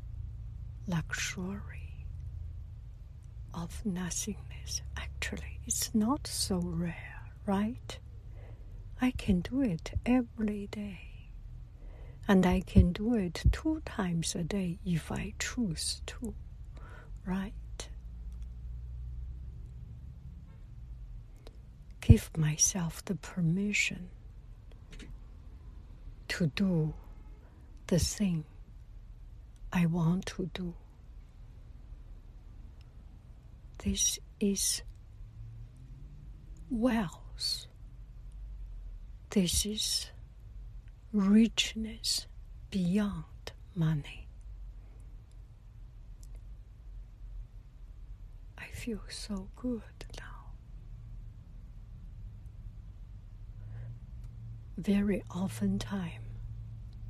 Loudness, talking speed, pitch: -33 LUFS, 60 wpm, 110 Hz